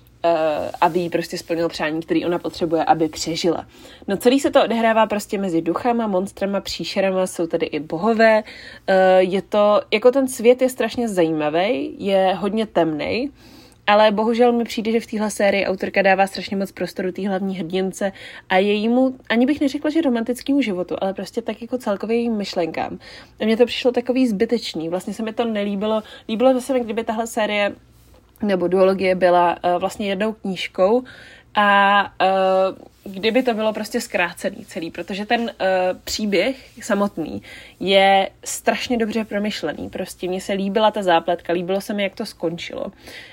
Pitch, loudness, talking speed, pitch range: 200 Hz, -20 LUFS, 165 wpm, 185-230 Hz